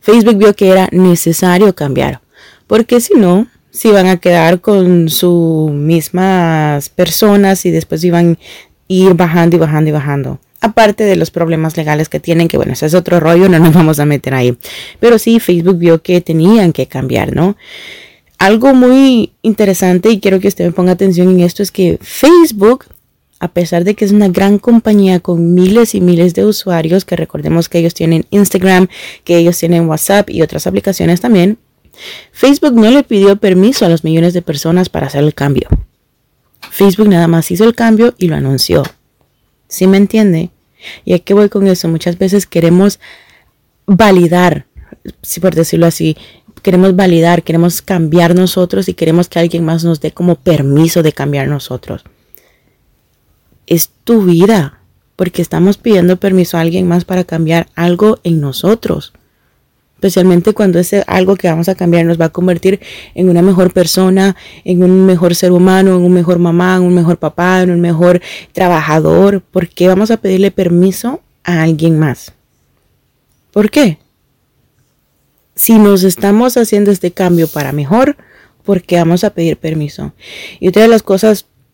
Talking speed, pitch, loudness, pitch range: 170 wpm, 180 Hz, -9 LUFS, 170-200 Hz